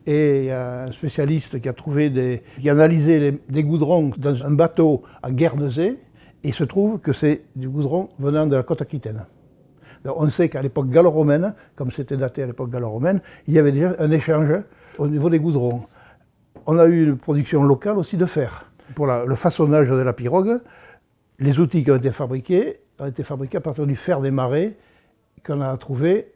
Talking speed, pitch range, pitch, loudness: 195 wpm, 135-165 Hz, 150 Hz, -20 LUFS